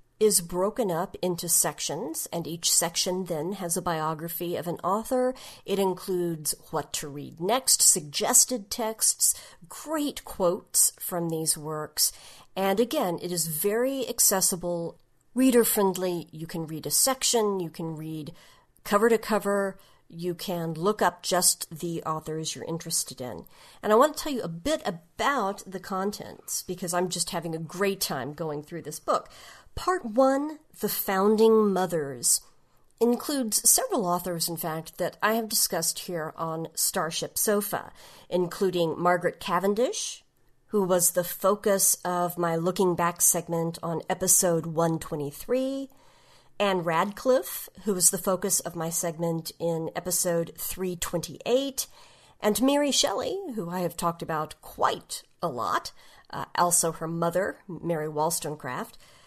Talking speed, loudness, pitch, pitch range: 145 wpm, -26 LUFS, 180 Hz, 165-205 Hz